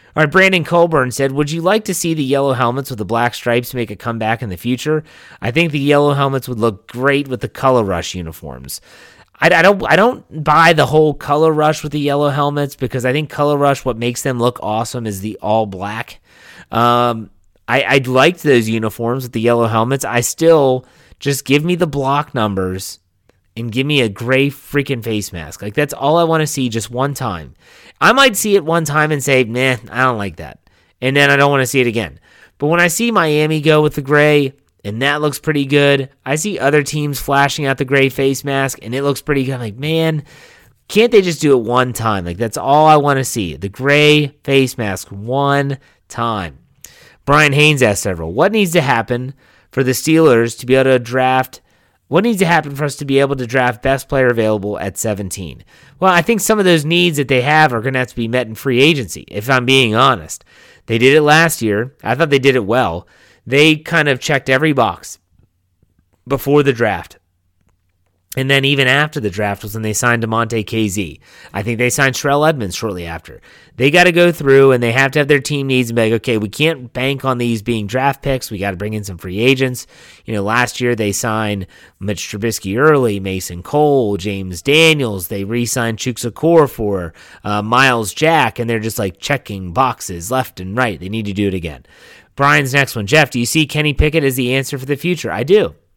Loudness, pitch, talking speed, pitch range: -15 LUFS, 130 Hz, 225 wpm, 110-145 Hz